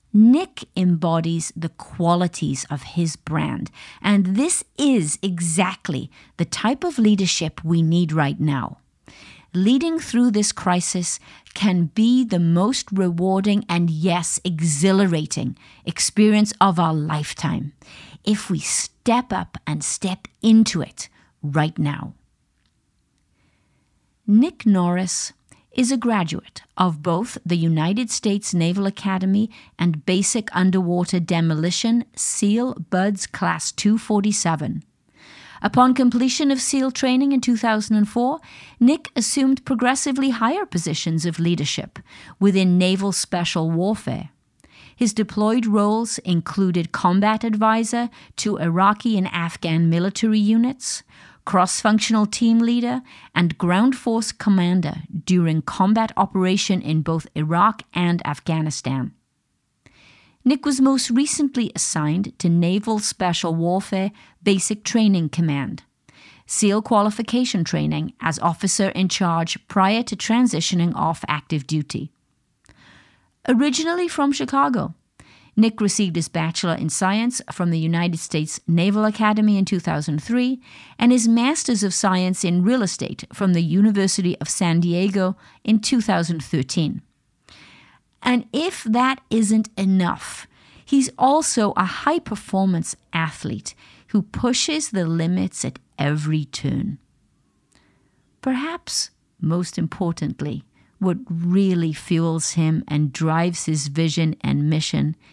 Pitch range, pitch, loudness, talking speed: 165-225 Hz, 190 Hz, -20 LUFS, 115 wpm